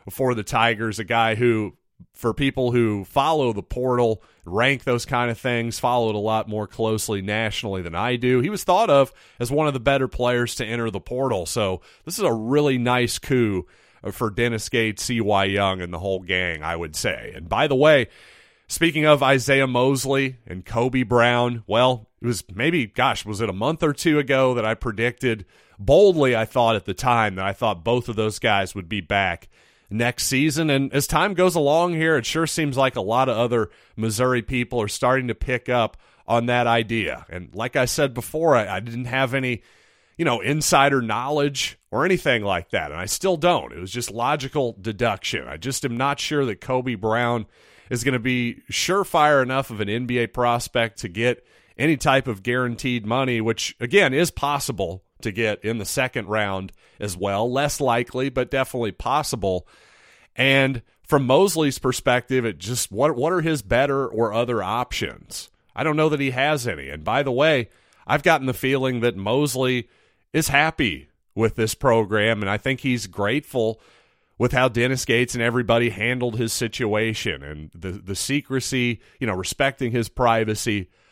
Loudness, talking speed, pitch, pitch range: -22 LUFS, 190 wpm, 120 Hz, 110-135 Hz